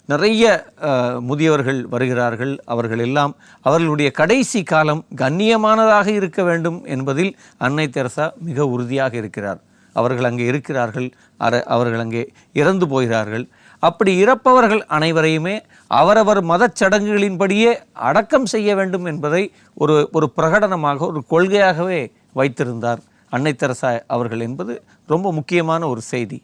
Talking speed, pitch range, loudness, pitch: 110 wpm, 125-195 Hz, -17 LUFS, 155 Hz